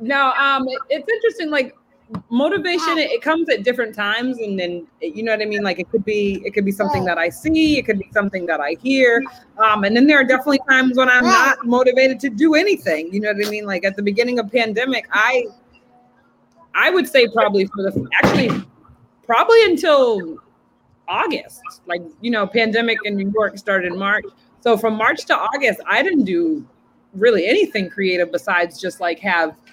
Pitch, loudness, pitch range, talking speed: 230 Hz, -17 LUFS, 200-280 Hz, 195 wpm